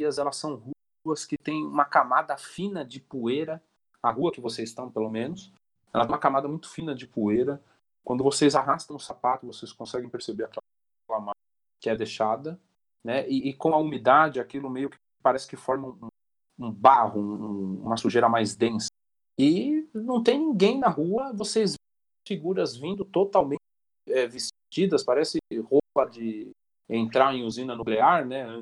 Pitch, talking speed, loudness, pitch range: 135 Hz, 165 wpm, -26 LUFS, 115-160 Hz